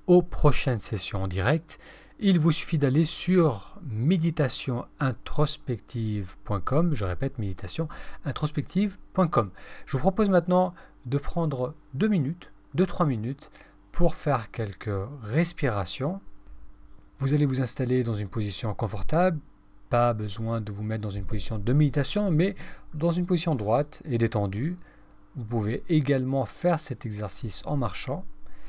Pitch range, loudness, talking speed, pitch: 110-165 Hz, -27 LUFS, 130 wpm, 135 Hz